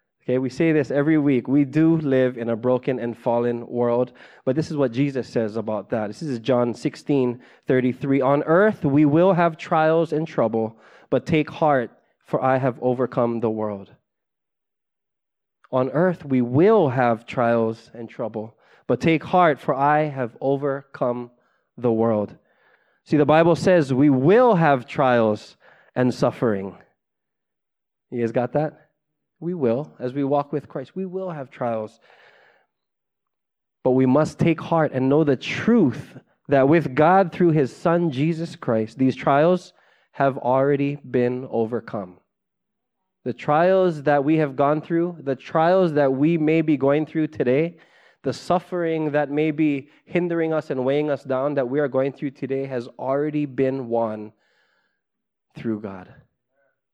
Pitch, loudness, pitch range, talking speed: 140 Hz, -21 LUFS, 125-155 Hz, 155 wpm